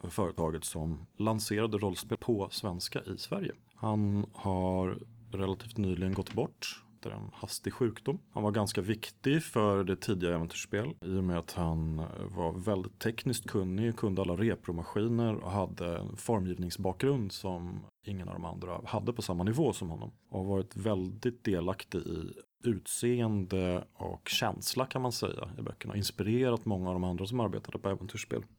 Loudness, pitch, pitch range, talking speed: -34 LUFS, 105 Hz, 95-115 Hz, 165 wpm